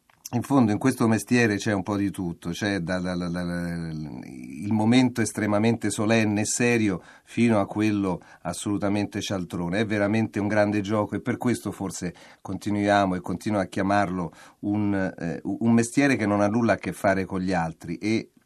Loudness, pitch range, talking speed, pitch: -25 LUFS, 95-110 Hz, 180 wpm, 105 Hz